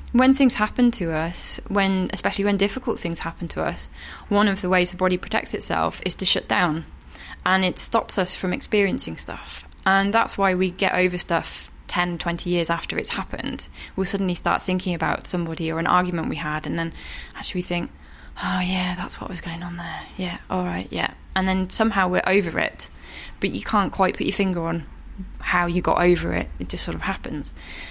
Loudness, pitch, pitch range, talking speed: -23 LUFS, 180 Hz, 165-190 Hz, 210 wpm